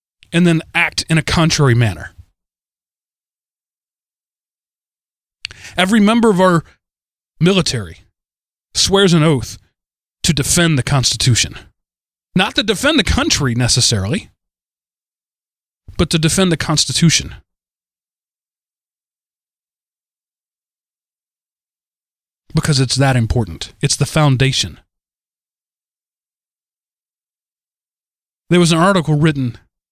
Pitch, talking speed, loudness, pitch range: 145 Hz, 85 wpm, -14 LUFS, 120-170 Hz